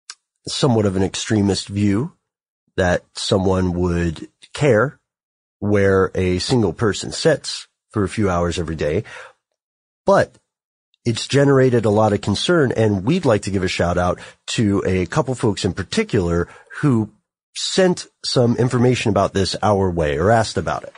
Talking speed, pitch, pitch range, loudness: 150 wpm, 100 Hz, 95-115 Hz, -19 LUFS